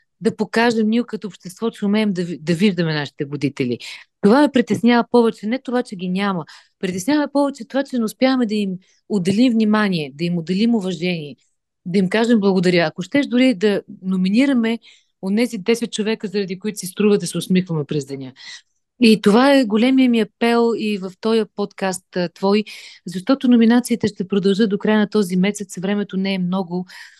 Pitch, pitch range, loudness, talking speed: 210 Hz, 185-230 Hz, -19 LUFS, 180 wpm